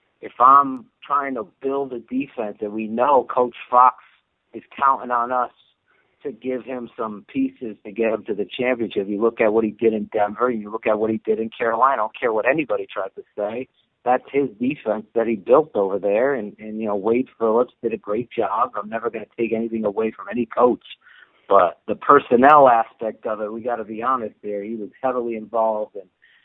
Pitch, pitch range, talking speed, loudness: 115 Hz, 110-125 Hz, 215 wpm, -21 LUFS